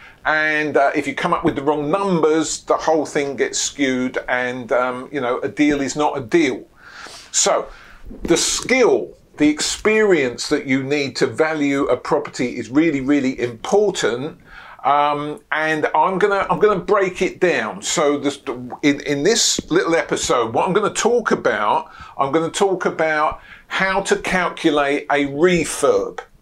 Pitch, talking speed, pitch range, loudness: 155 Hz, 160 wpm, 145-190 Hz, -18 LUFS